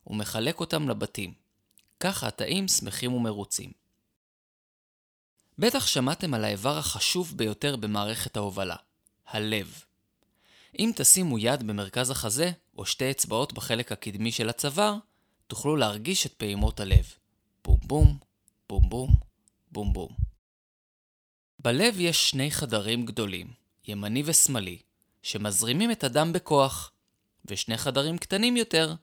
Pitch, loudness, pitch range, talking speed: 115 Hz, -26 LUFS, 105-150 Hz, 110 wpm